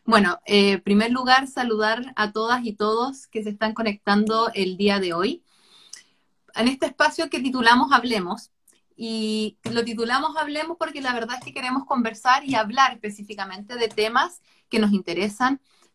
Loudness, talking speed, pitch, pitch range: -22 LUFS, 160 wpm, 230 Hz, 215-260 Hz